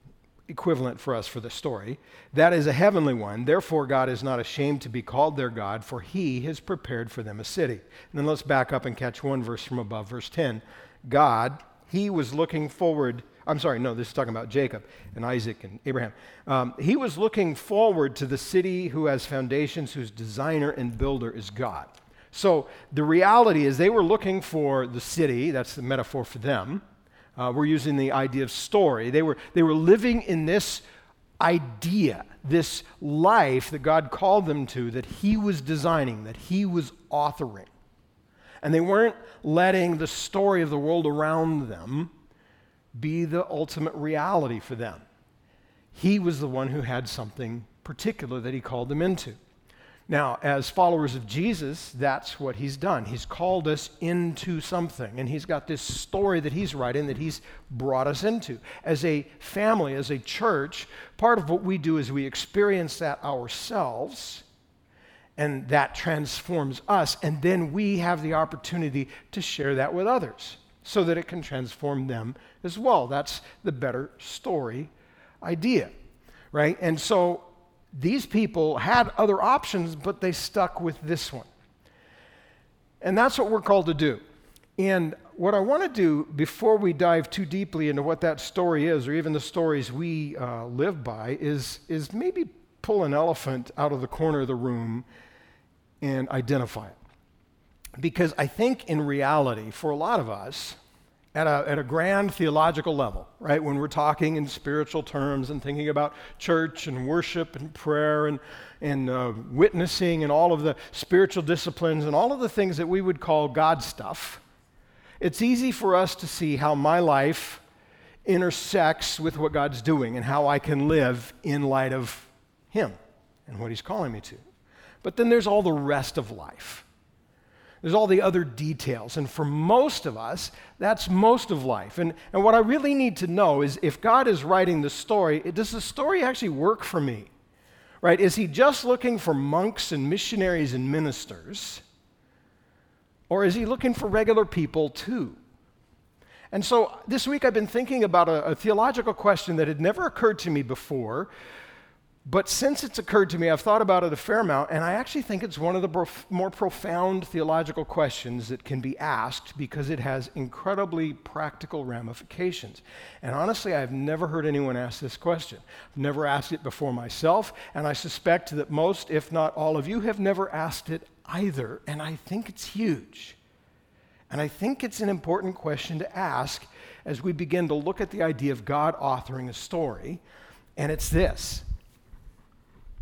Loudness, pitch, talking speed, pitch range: -26 LUFS, 155 Hz, 180 wpm, 135-180 Hz